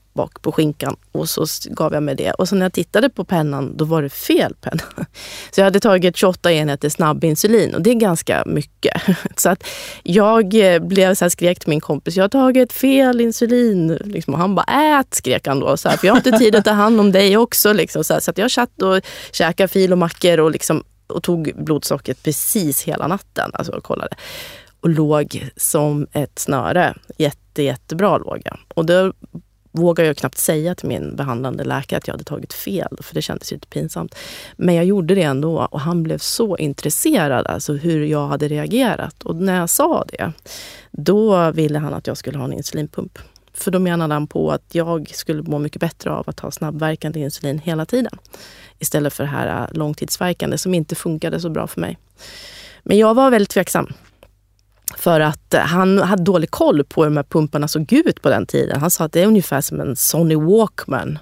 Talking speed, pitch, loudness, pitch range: 200 wpm, 170 Hz, -17 LUFS, 150-195 Hz